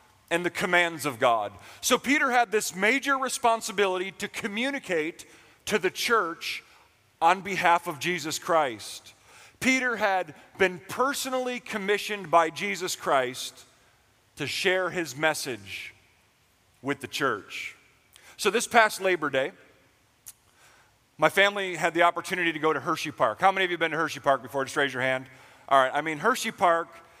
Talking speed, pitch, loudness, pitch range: 155 wpm, 170 Hz, -26 LUFS, 140-205 Hz